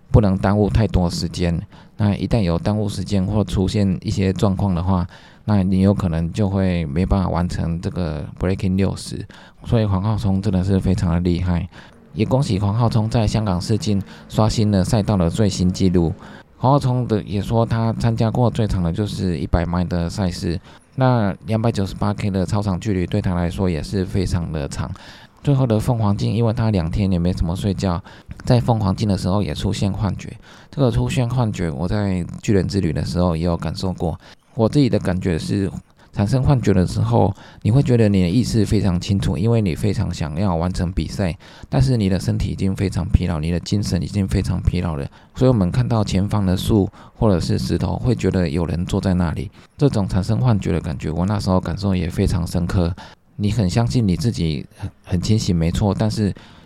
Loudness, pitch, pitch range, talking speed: -20 LUFS, 95 Hz, 90-110 Hz, 310 characters per minute